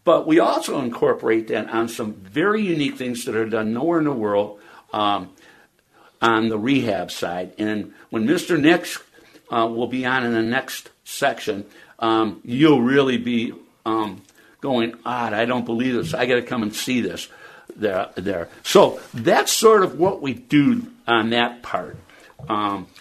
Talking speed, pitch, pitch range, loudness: 170 wpm, 115 Hz, 110-130 Hz, -21 LUFS